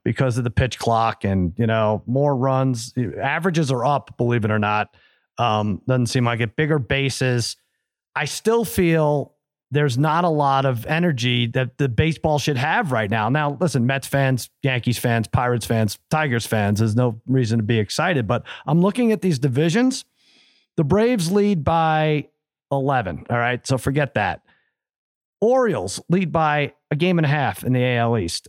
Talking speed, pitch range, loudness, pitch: 180 wpm, 120-155 Hz, -21 LUFS, 135 Hz